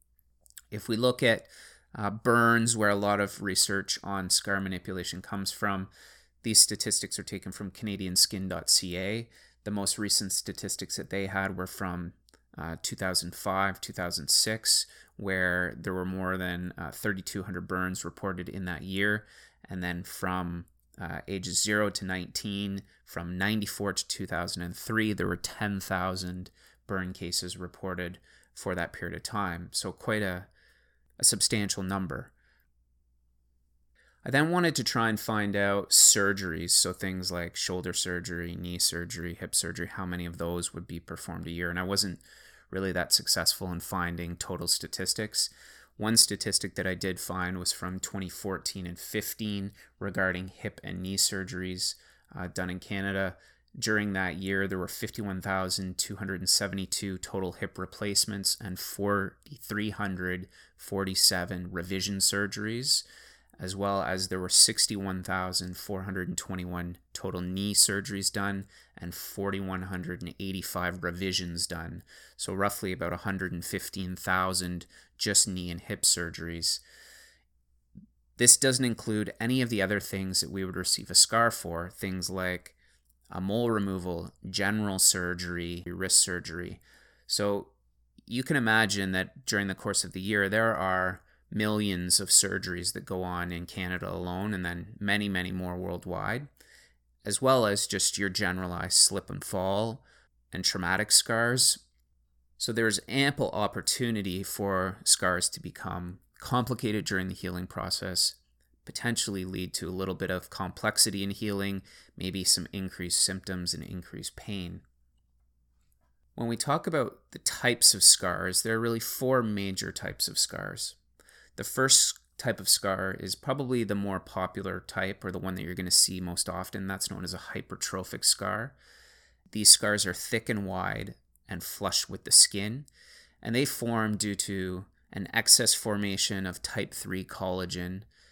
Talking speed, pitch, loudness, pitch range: 140 wpm, 95 Hz, -28 LUFS, 90-100 Hz